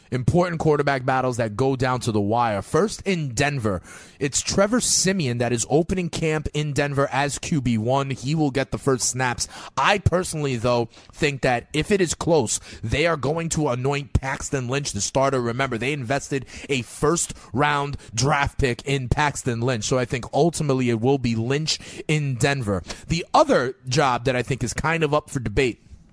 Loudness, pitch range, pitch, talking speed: -22 LUFS, 120-150 Hz, 135 Hz, 185 wpm